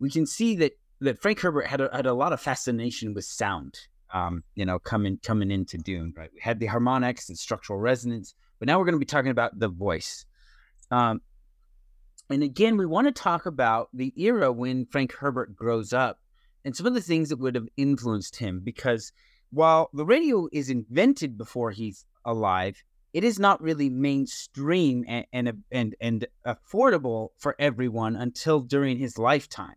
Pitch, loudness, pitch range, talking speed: 125 Hz, -26 LUFS, 115-145 Hz, 185 wpm